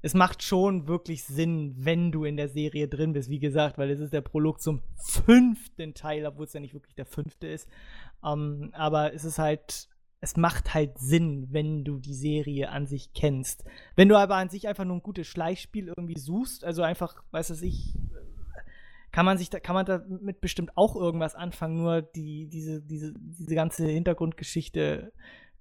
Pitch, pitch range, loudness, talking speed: 160 Hz, 150-175 Hz, -28 LUFS, 190 wpm